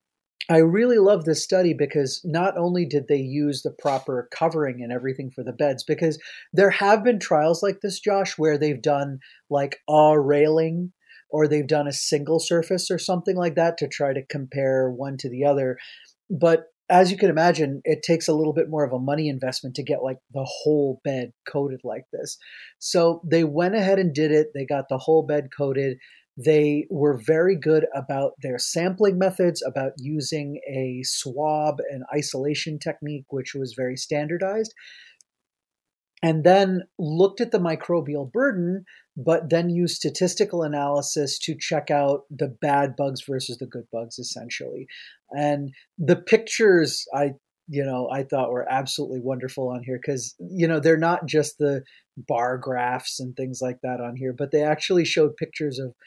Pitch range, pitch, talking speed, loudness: 135-170 Hz, 150 Hz, 175 wpm, -23 LUFS